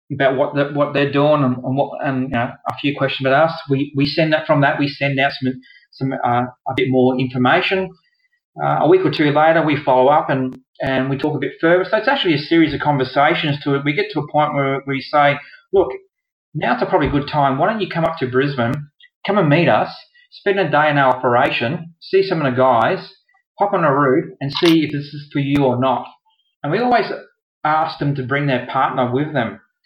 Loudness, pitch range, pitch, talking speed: -17 LUFS, 135-165 Hz, 145 Hz, 240 wpm